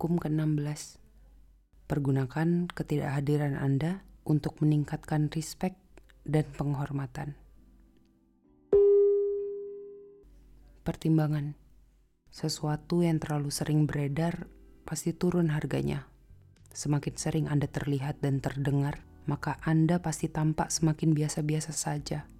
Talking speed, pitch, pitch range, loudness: 85 wpm, 150 Hz, 145-165 Hz, -30 LUFS